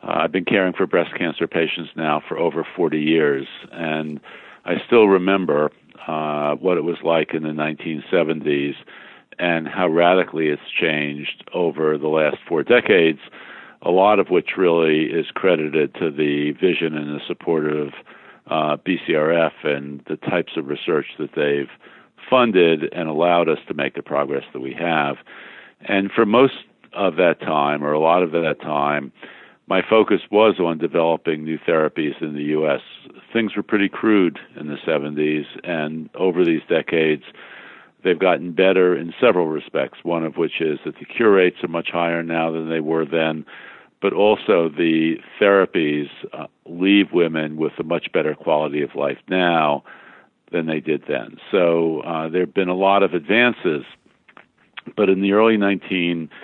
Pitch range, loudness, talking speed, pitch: 75-90 Hz, -19 LUFS, 165 wpm, 80 Hz